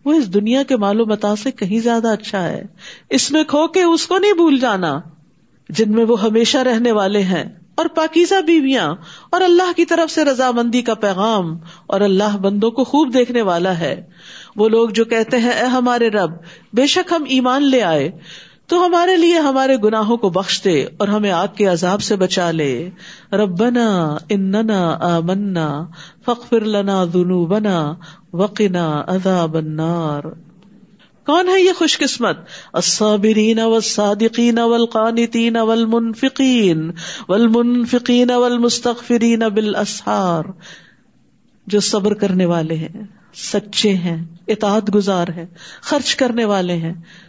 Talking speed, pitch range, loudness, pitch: 140 wpm, 185-245 Hz, -16 LUFS, 215 Hz